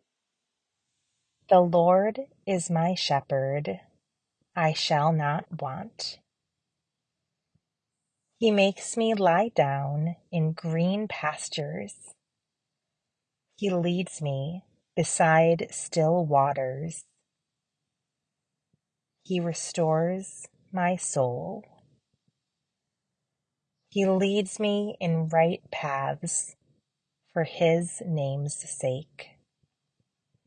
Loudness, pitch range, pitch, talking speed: -27 LUFS, 145-180 Hz, 165 Hz, 75 wpm